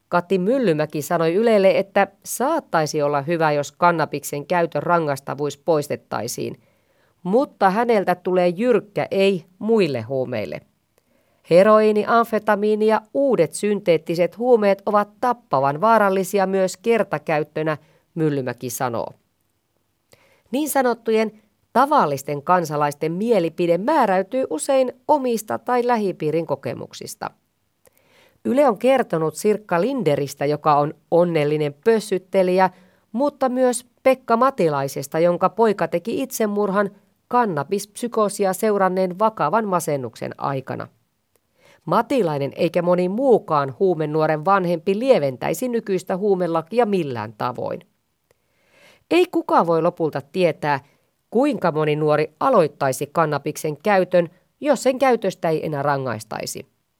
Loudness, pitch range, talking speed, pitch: -20 LUFS, 155-220 Hz, 100 wpm, 180 Hz